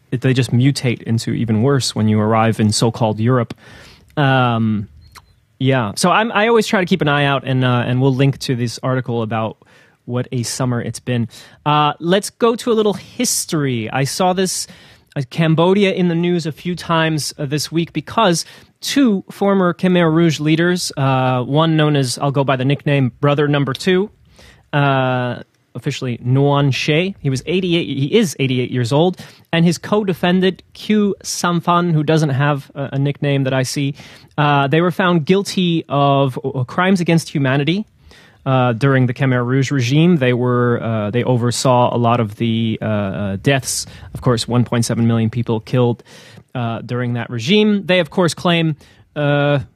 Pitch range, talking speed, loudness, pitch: 125-170 Hz, 175 wpm, -17 LUFS, 140 Hz